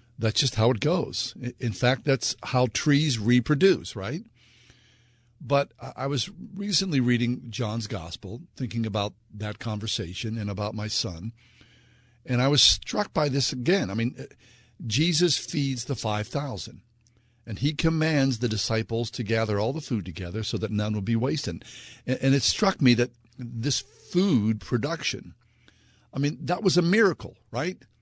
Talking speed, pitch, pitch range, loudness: 155 wpm, 120 Hz, 110-140 Hz, -26 LUFS